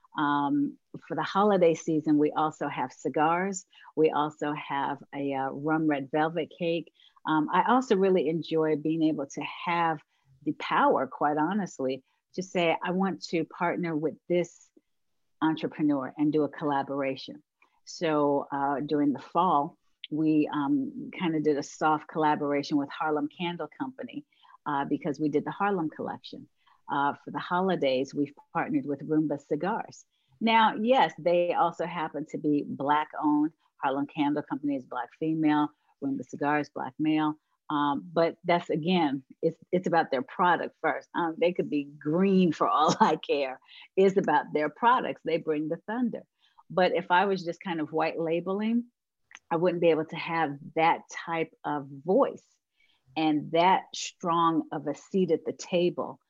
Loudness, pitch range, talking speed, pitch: -28 LUFS, 150-180 Hz, 160 wpm, 160 Hz